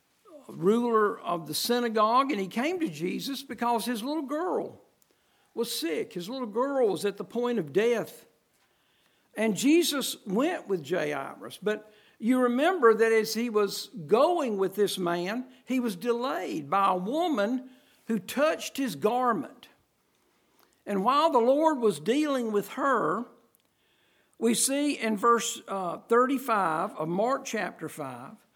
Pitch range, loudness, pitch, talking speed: 210-275 Hz, -27 LUFS, 235 Hz, 145 wpm